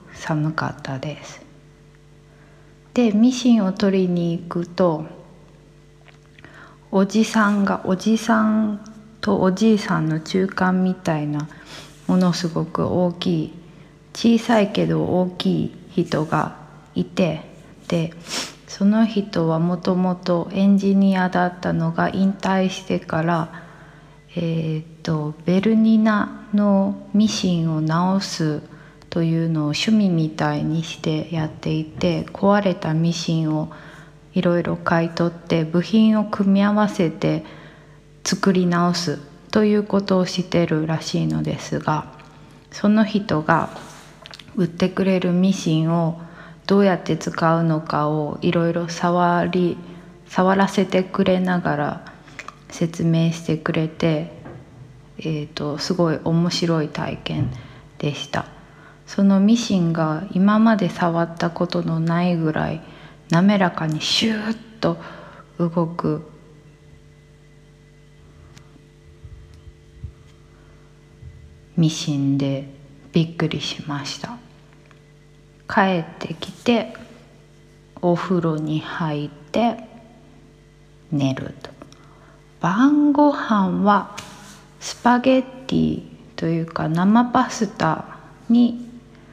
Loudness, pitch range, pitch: -20 LUFS, 155-195 Hz, 170 Hz